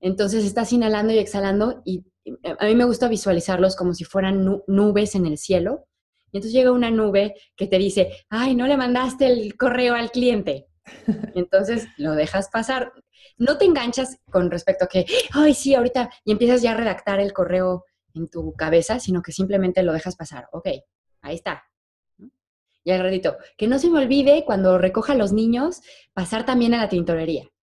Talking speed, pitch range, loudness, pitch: 185 wpm, 185-245 Hz, -21 LUFS, 210 Hz